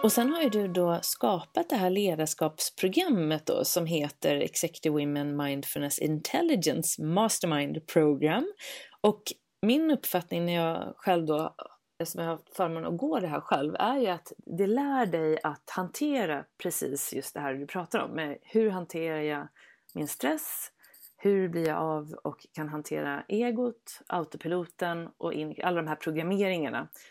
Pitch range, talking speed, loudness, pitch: 155-210 Hz, 150 wpm, -30 LUFS, 170 Hz